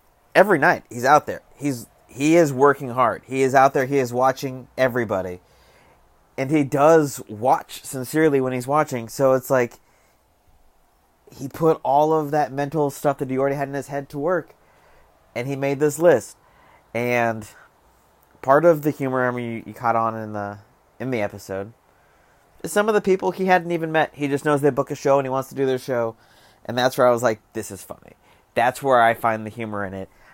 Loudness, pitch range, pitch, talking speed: -21 LUFS, 115-145 Hz, 130 Hz, 210 wpm